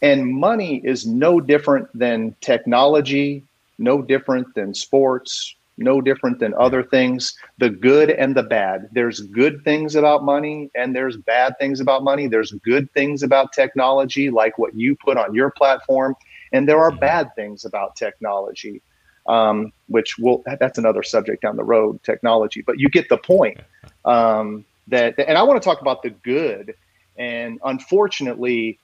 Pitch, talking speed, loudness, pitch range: 135 Hz, 160 wpm, -18 LUFS, 120-145 Hz